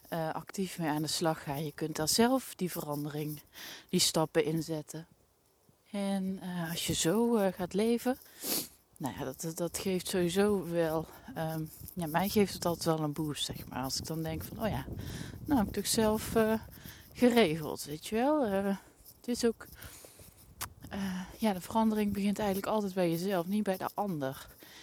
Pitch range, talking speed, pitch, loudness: 155-205 Hz, 185 wpm, 175 Hz, -33 LUFS